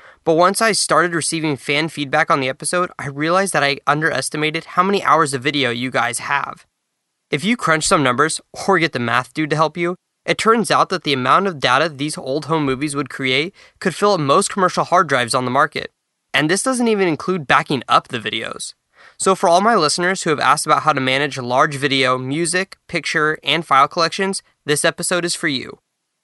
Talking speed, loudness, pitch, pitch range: 215 wpm, -17 LUFS, 160 Hz, 145-180 Hz